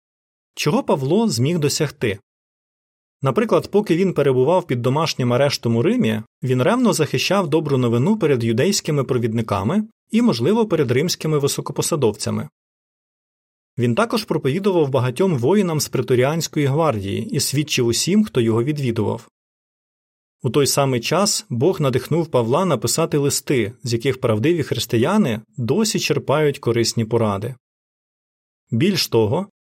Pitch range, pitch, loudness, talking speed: 120-170 Hz, 140 Hz, -19 LUFS, 120 wpm